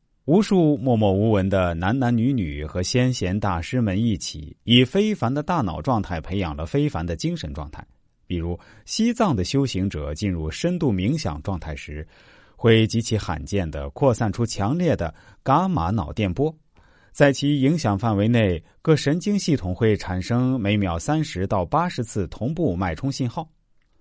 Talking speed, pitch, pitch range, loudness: 250 characters per minute, 110 Hz, 95-140 Hz, -22 LUFS